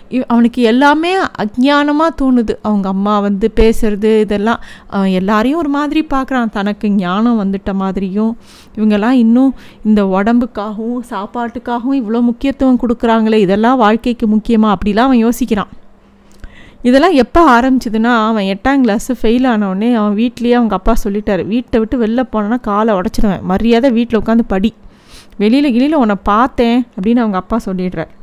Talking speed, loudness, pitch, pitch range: 135 wpm, -13 LUFS, 230 Hz, 210-250 Hz